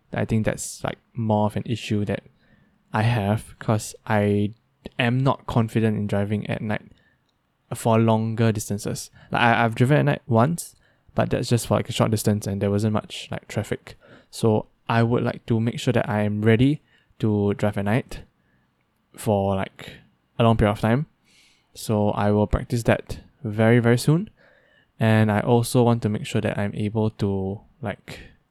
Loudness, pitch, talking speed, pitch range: -23 LUFS, 110 Hz, 180 wpm, 105-120 Hz